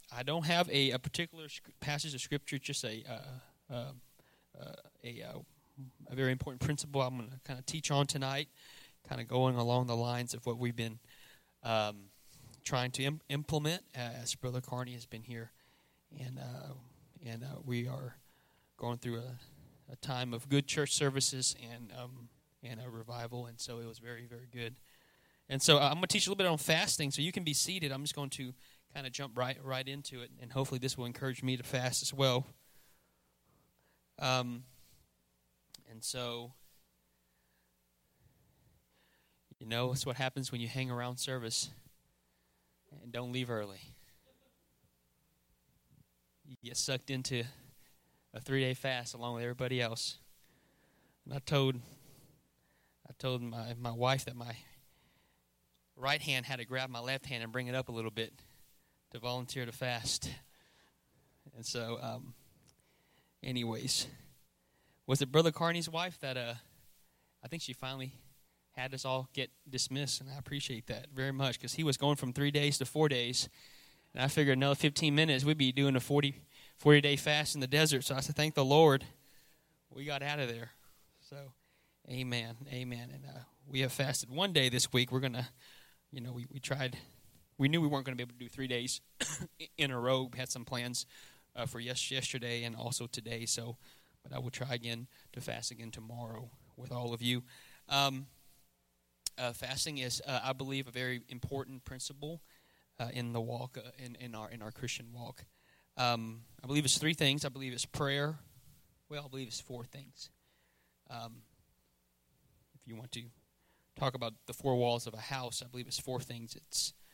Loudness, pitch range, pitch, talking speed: -35 LUFS, 120-140 Hz, 125 Hz, 180 wpm